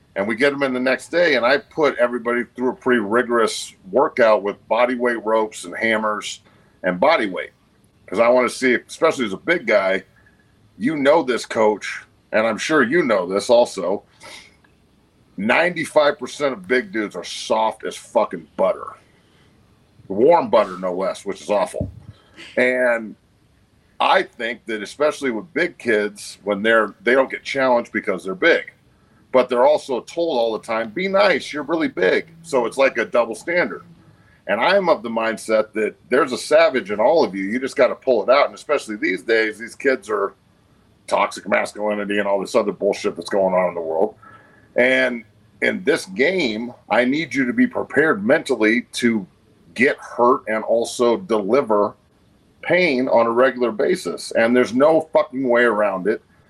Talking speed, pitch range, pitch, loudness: 175 wpm, 105-125 Hz, 115 Hz, -19 LUFS